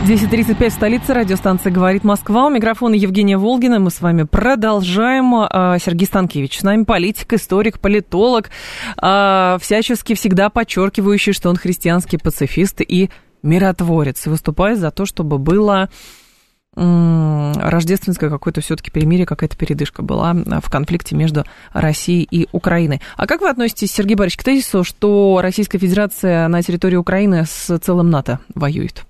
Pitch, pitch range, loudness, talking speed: 190 Hz, 170-210 Hz, -15 LUFS, 140 wpm